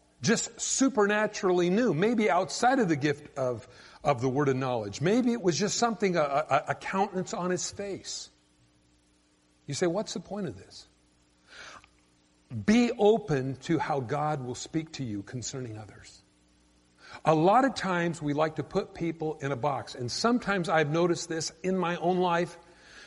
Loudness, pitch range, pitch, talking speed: -28 LUFS, 120-190 Hz, 160 Hz, 170 wpm